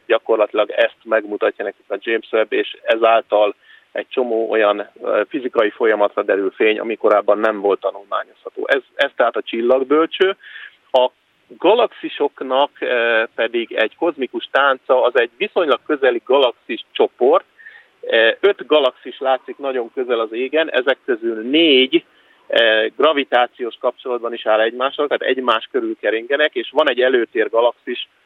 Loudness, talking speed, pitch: -17 LUFS, 130 wpm, 390 Hz